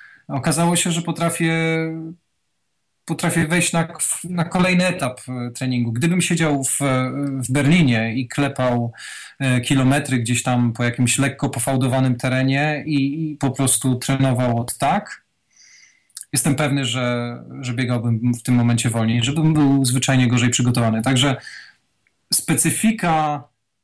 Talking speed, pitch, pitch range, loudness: 125 wpm, 135 Hz, 125-160 Hz, -19 LUFS